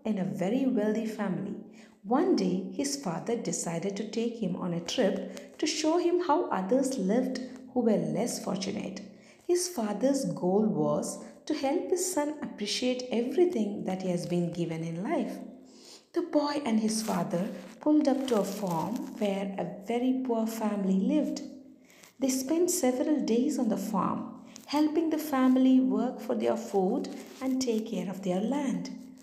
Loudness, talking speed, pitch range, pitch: -30 LUFS, 160 wpm, 200-270 Hz, 240 Hz